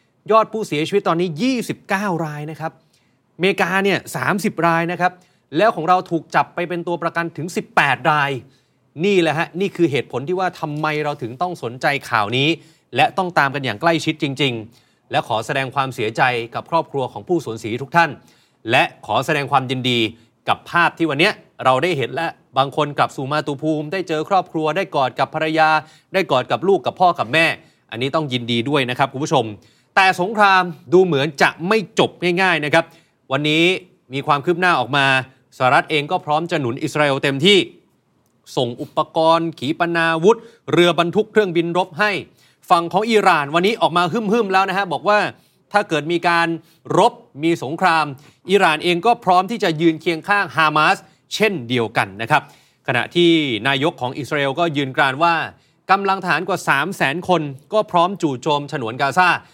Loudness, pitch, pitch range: -18 LUFS, 165 Hz, 145-180 Hz